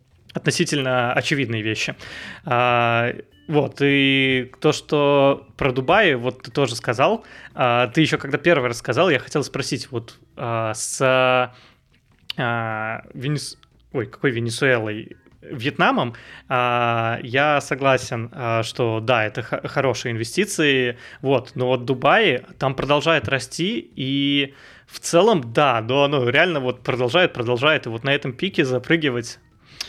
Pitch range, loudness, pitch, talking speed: 120-145 Hz, -20 LUFS, 130 Hz, 130 wpm